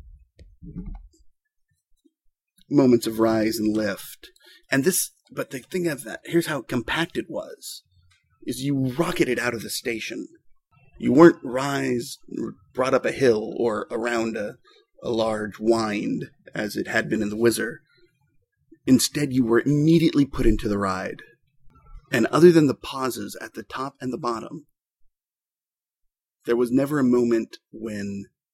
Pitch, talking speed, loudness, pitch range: 130 Hz, 145 wpm, -23 LUFS, 110-160 Hz